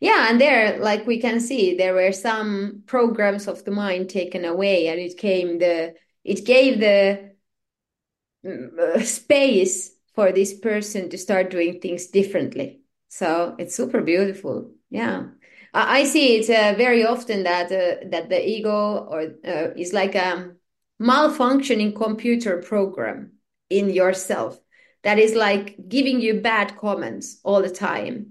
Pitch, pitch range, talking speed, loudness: 200 Hz, 185-230 Hz, 145 wpm, -20 LUFS